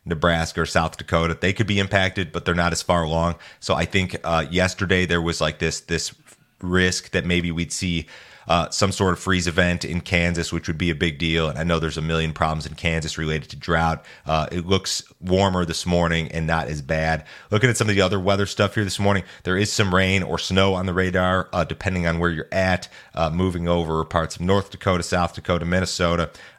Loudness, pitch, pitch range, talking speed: -22 LUFS, 85 Hz, 85-95 Hz, 230 wpm